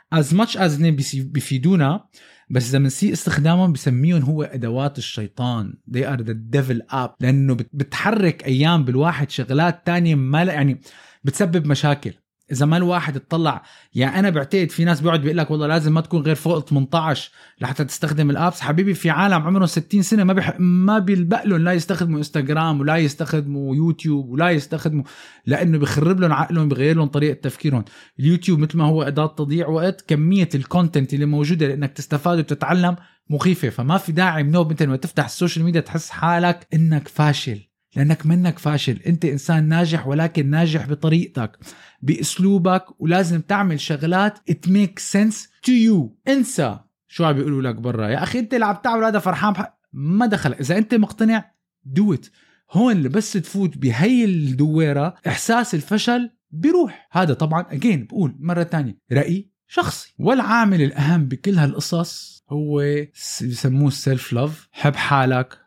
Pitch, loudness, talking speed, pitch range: 160 Hz, -19 LUFS, 155 wpm, 140-180 Hz